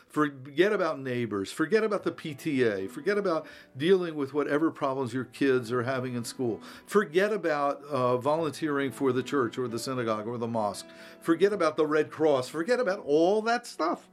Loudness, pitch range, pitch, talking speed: -28 LUFS, 125-165 Hz, 145 Hz, 180 wpm